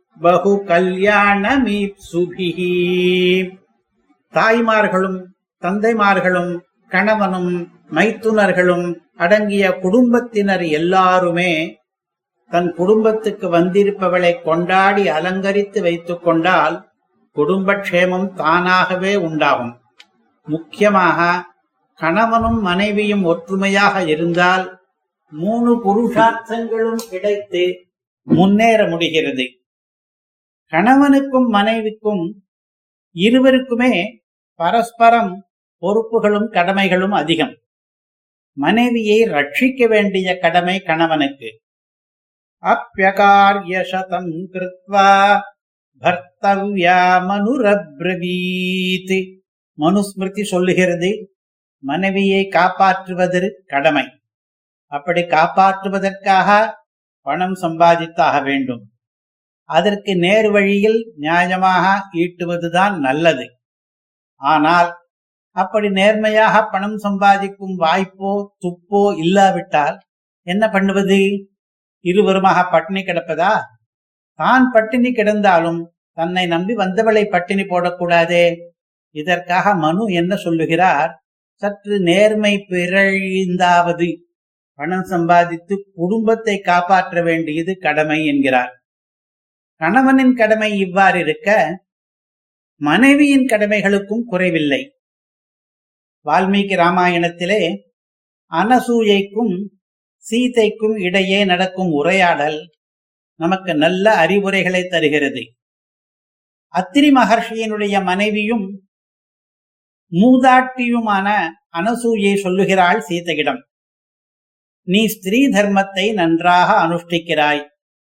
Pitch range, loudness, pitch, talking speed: 175-205 Hz, -15 LUFS, 190 Hz, 60 wpm